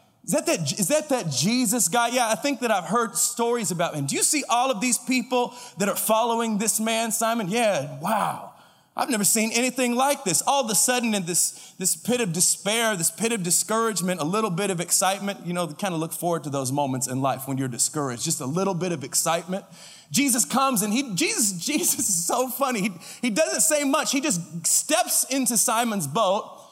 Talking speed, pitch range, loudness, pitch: 220 wpm, 175-250 Hz, -23 LUFS, 220 Hz